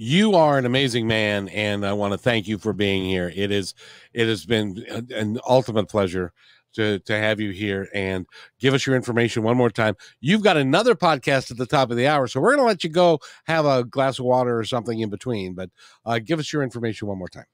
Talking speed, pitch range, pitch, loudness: 240 wpm, 105-135 Hz, 115 Hz, -22 LUFS